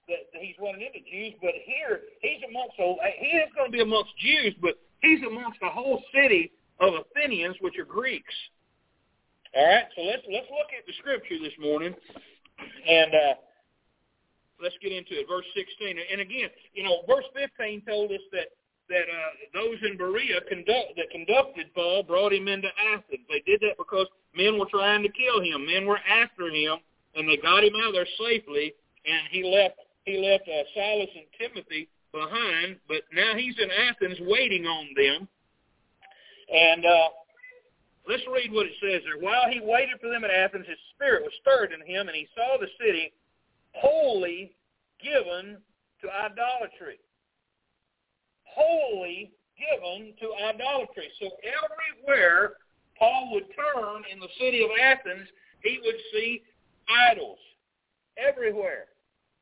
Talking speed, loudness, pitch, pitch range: 160 wpm, -25 LUFS, 215 Hz, 180-290 Hz